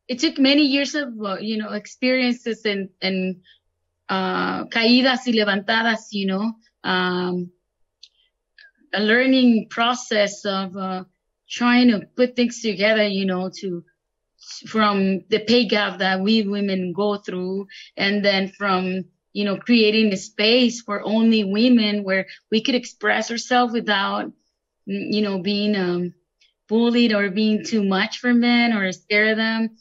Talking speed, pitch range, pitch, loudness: 140 wpm, 195-235 Hz, 210 Hz, -20 LUFS